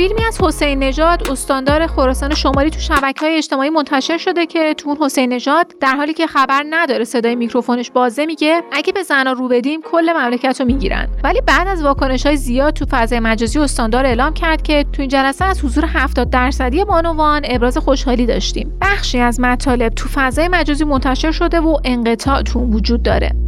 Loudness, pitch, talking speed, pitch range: -15 LUFS, 280 Hz, 185 wpm, 255-315 Hz